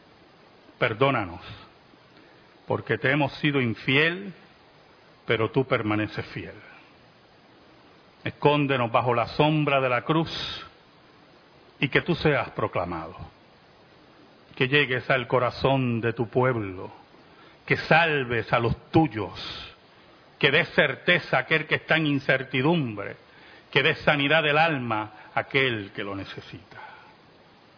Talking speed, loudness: 115 wpm, -24 LUFS